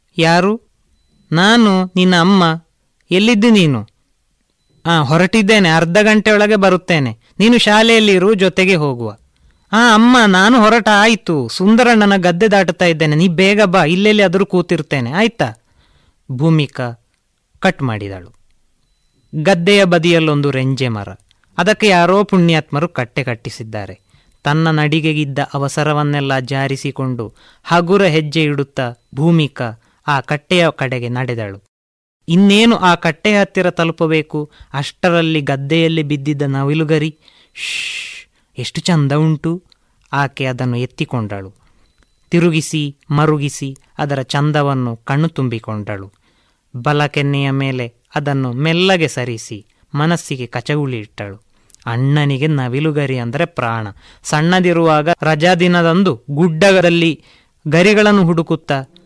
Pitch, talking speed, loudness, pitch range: 150 Hz, 95 wpm, -13 LUFS, 130-180 Hz